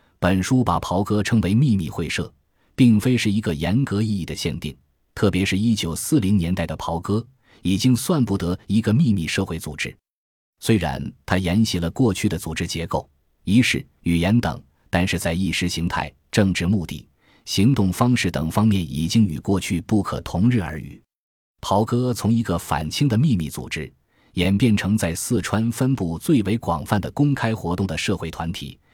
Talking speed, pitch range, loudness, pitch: 260 characters per minute, 85-110 Hz, -21 LUFS, 95 Hz